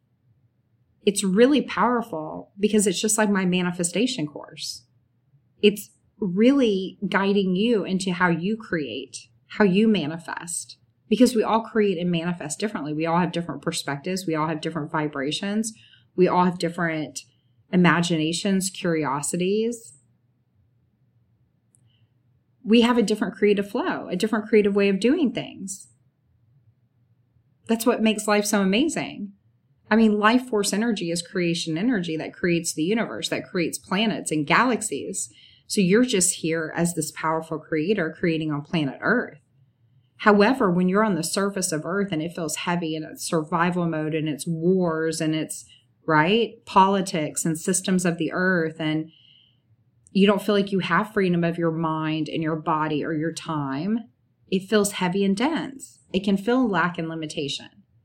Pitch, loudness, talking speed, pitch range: 170 Hz, -23 LUFS, 155 wpm, 150-205 Hz